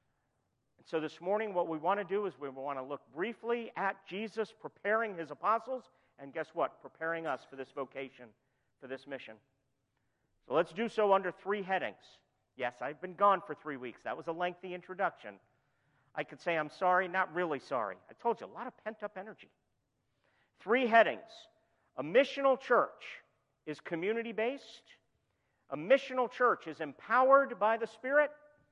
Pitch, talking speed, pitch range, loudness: 180 Hz, 170 wpm, 135-220 Hz, -34 LUFS